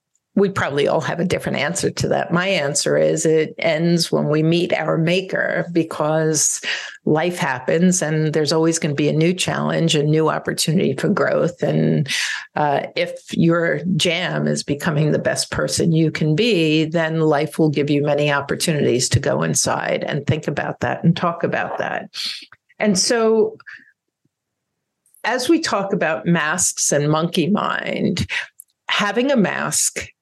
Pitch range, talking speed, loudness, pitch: 155-180 Hz, 160 wpm, -19 LUFS, 165 Hz